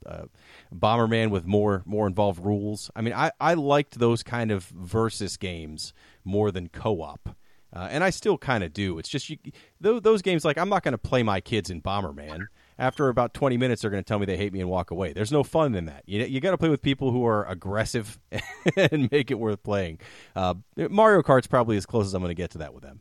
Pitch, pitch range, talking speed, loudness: 110 Hz, 95-140 Hz, 250 wpm, -25 LUFS